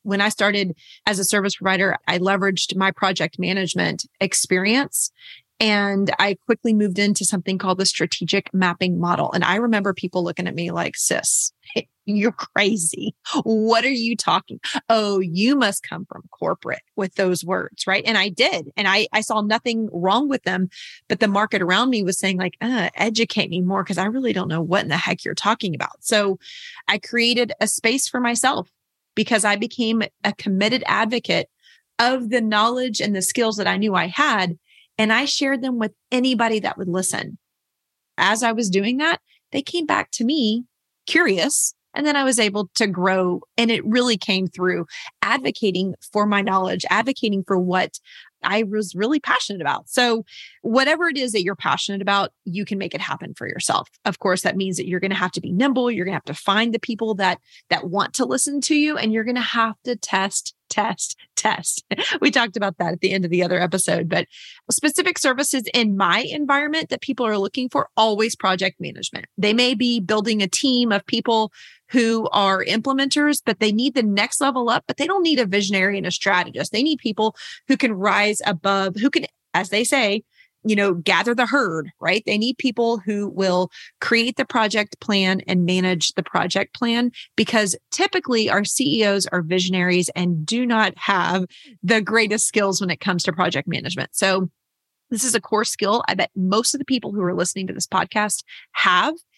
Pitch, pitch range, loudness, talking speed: 210 Hz, 190-240 Hz, -20 LUFS, 195 wpm